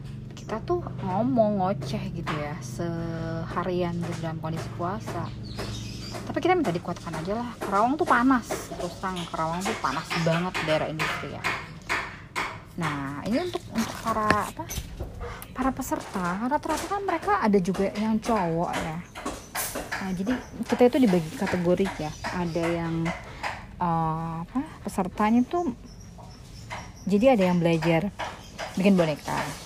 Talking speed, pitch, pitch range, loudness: 130 wpm, 180 Hz, 165-230 Hz, -27 LUFS